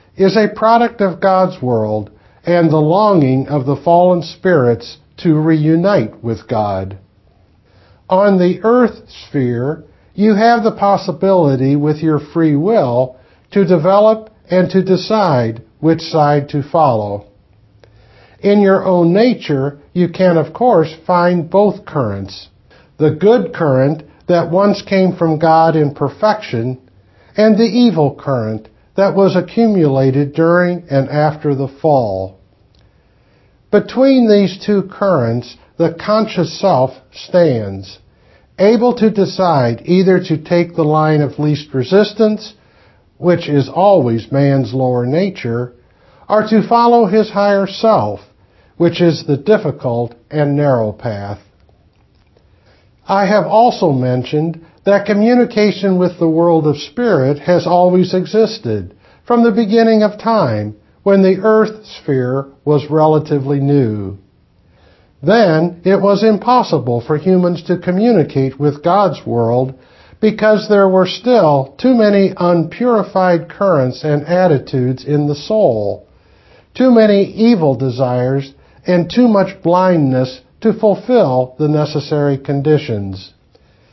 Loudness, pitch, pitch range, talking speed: -13 LUFS, 160 Hz, 130-195 Hz, 125 wpm